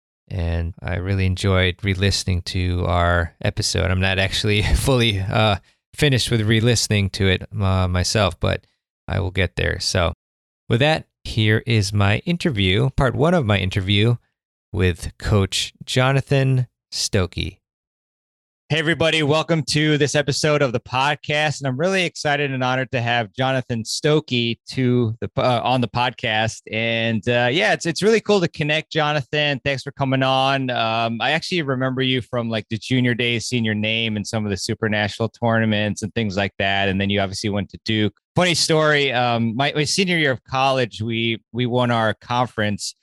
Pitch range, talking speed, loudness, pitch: 100-135 Hz, 175 wpm, -20 LUFS, 115 Hz